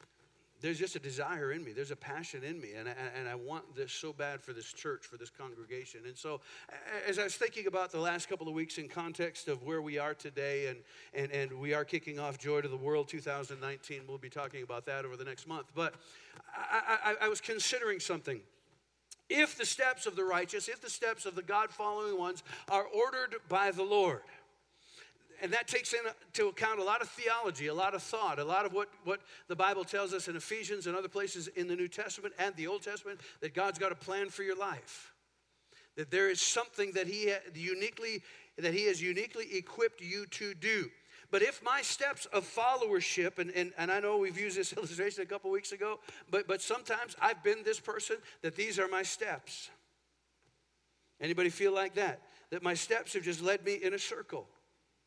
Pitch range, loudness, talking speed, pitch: 165-225 Hz, -36 LUFS, 210 wpm, 195 Hz